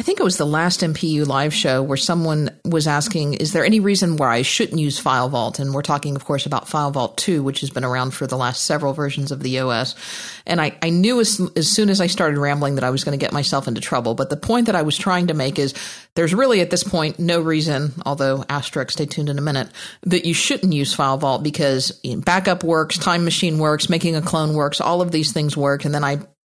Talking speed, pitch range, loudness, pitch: 250 wpm, 140-175 Hz, -19 LUFS, 150 Hz